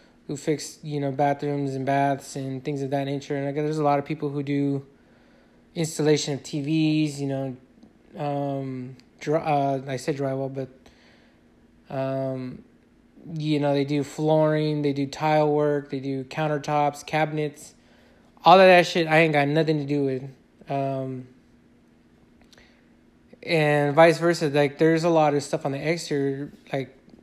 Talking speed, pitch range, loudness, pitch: 160 wpm, 135-155 Hz, -24 LUFS, 145 Hz